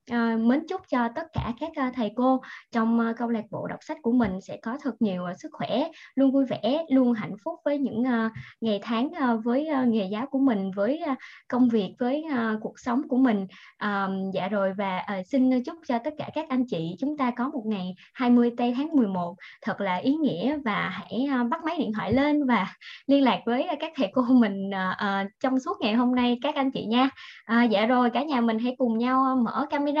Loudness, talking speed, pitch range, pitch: -26 LUFS, 205 wpm, 220-270 Hz, 245 Hz